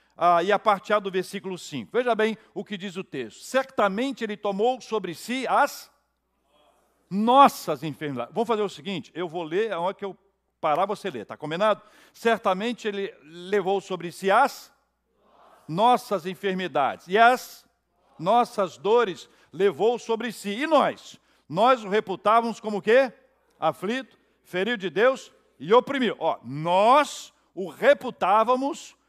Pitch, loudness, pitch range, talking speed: 210 Hz, -24 LUFS, 190-240 Hz, 145 wpm